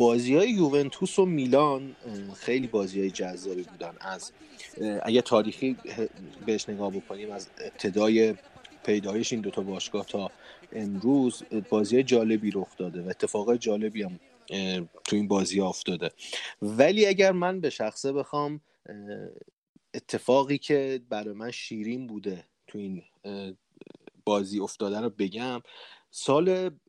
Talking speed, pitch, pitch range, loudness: 125 wpm, 110 Hz, 100-130 Hz, -28 LUFS